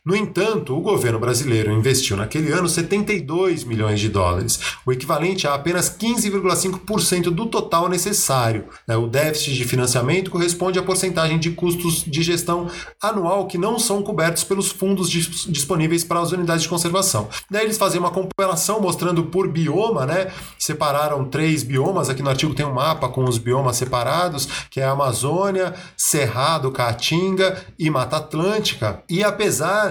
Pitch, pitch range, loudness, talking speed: 170 Hz, 140-185 Hz, -20 LUFS, 155 wpm